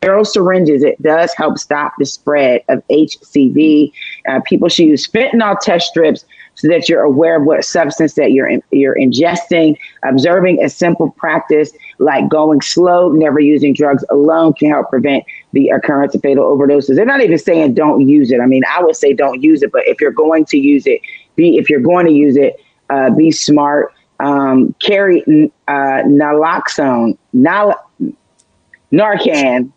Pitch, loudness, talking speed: 165 Hz, -11 LUFS, 175 wpm